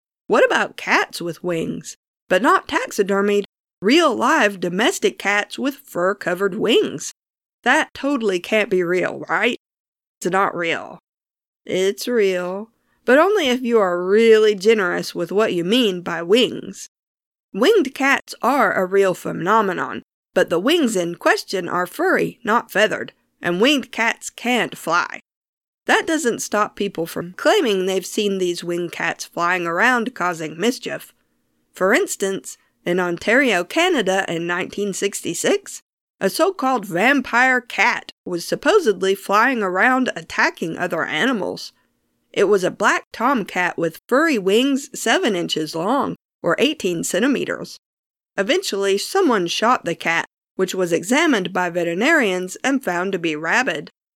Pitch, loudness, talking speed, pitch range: 205 Hz, -19 LUFS, 135 wpm, 180-255 Hz